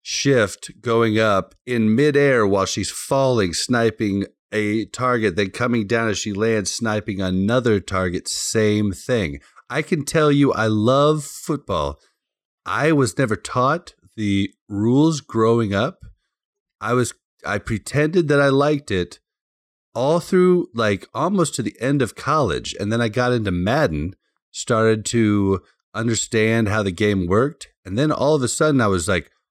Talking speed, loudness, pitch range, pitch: 155 wpm, -20 LUFS, 100-135 Hz, 110 Hz